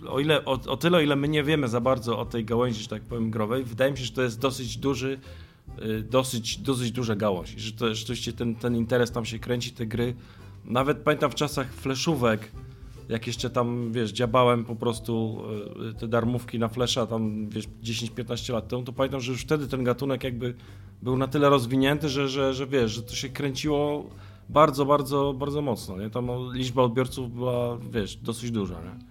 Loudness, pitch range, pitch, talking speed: -27 LUFS, 115-135 Hz, 120 Hz, 210 wpm